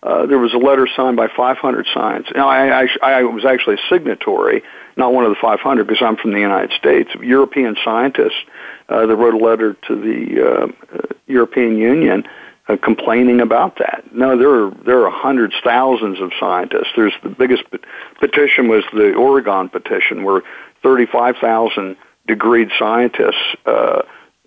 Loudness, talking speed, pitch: -14 LUFS, 165 wpm, 125 Hz